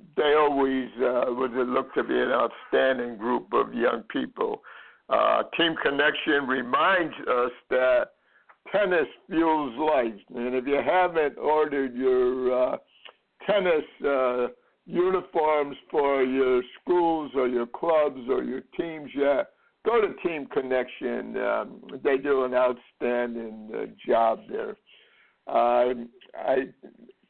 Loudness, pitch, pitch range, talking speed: -25 LUFS, 130 Hz, 125-155 Hz, 125 wpm